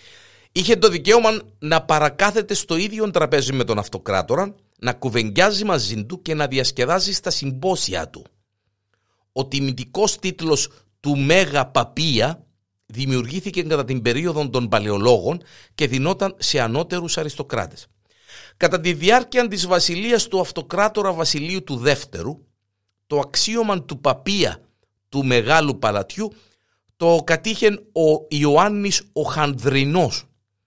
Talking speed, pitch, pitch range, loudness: 120 wpm, 155 Hz, 130-190 Hz, -20 LUFS